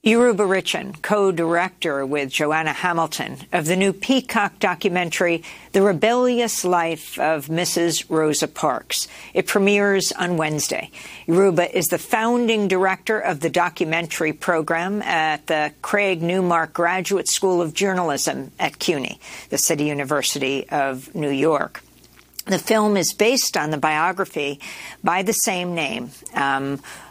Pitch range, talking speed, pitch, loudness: 155-195 Hz, 130 wpm, 175 Hz, -20 LUFS